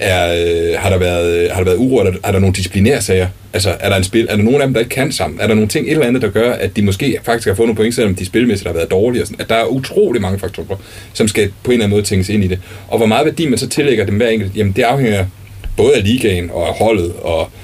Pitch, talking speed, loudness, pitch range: 100 Hz, 310 wpm, -14 LUFS, 95-110 Hz